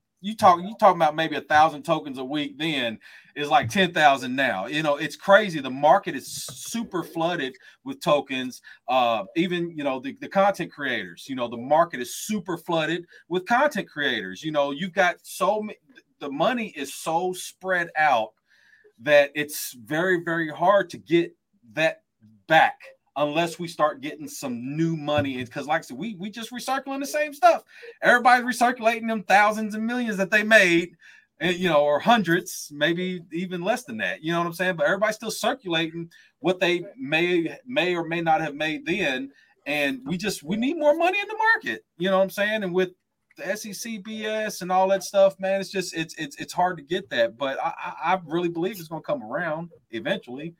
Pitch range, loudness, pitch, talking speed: 155-220 Hz, -24 LUFS, 180 Hz, 195 wpm